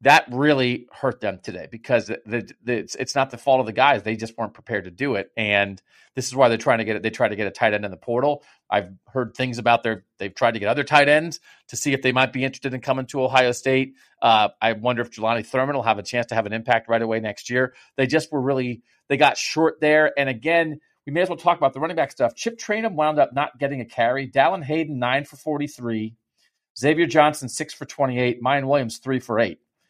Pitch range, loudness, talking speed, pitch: 115-145 Hz, -22 LUFS, 255 wpm, 130 Hz